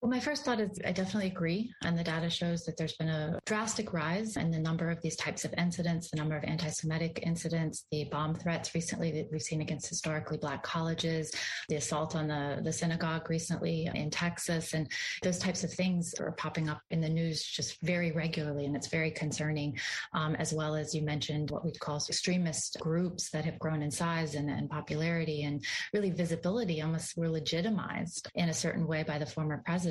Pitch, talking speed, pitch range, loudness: 160 Hz, 205 wpm, 155-170 Hz, -34 LUFS